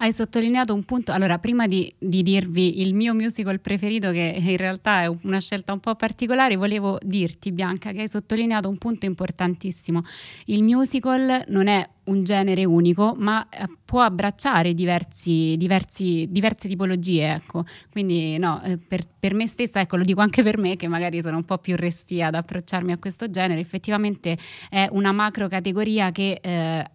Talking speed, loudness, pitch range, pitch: 170 wpm, -22 LUFS, 180-210 Hz, 190 Hz